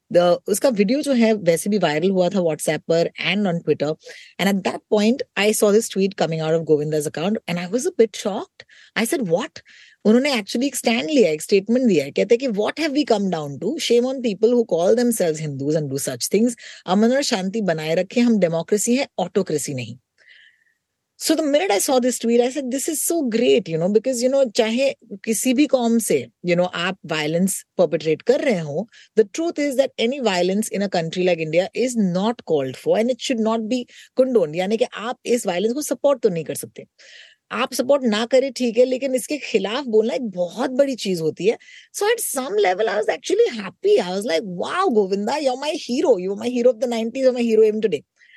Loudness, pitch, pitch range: -20 LUFS, 225 Hz, 180-260 Hz